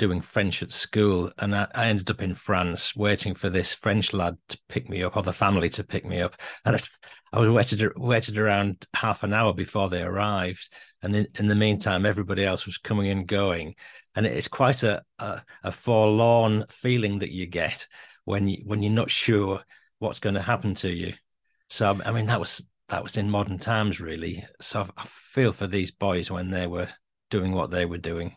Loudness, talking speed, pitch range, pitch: -25 LUFS, 210 wpm, 90-105 Hz, 100 Hz